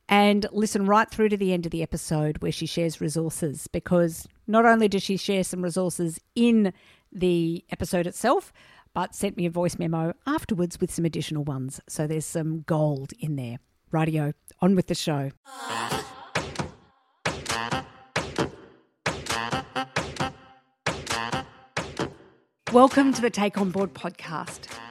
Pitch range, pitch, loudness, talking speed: 135-190 Hz, 165 Hz, -26 LUFS, 135 wpm